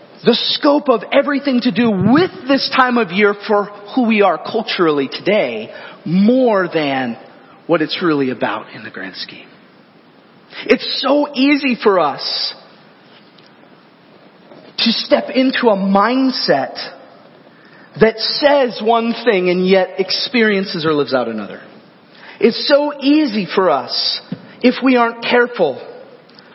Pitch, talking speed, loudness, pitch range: 230 Hz, 130 wpm, -15 LUFS, 195-265 Hz